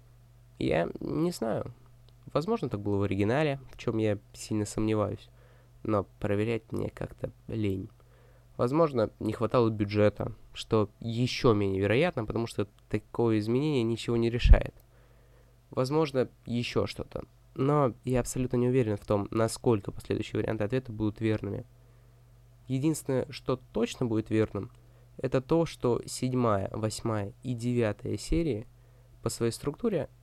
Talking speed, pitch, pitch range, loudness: 130 wpm, 120 Hz, 110-125 Hz, -30 LUFS